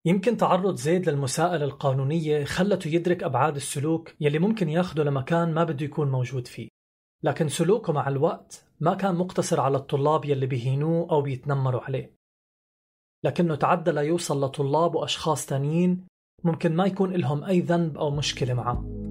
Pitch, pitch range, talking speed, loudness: 155 Hz, 140-175 Hz, 150 wpm, -25 LUFS